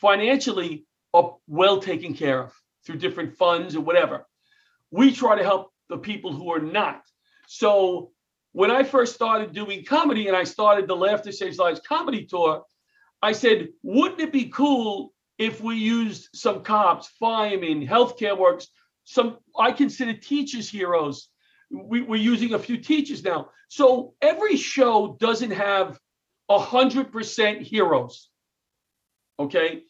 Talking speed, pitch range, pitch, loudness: 145 wpm, 195-265 Hz, 220 Hz, -22 LUFS